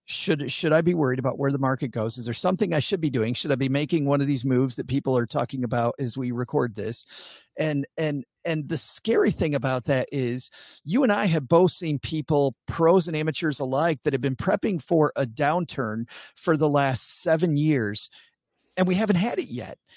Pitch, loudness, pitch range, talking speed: 145 Hz, -25 LUFS, 130-160 Hz, 215 wpm